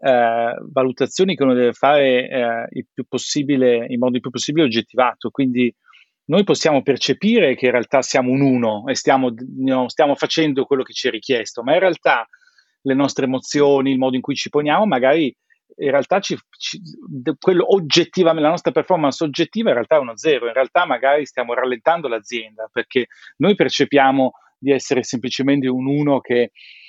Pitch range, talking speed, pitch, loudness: 125-150 Hz, 175 wpm, 135 Hz, -18 LUFS